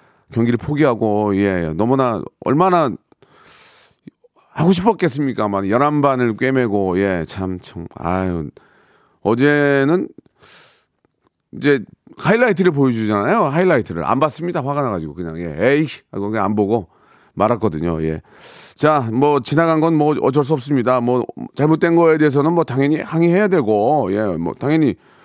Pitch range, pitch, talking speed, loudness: 100-155 Hz, 130 Hz, 290 characters per minute, -17 LUFS